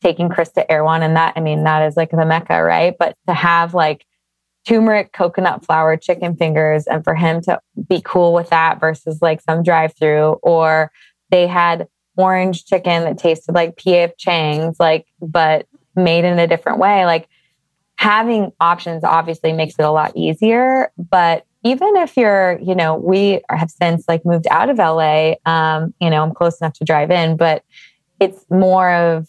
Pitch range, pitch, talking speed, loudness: 160-180 Hz, 170 Hz, 180 wpm, -15 LUFS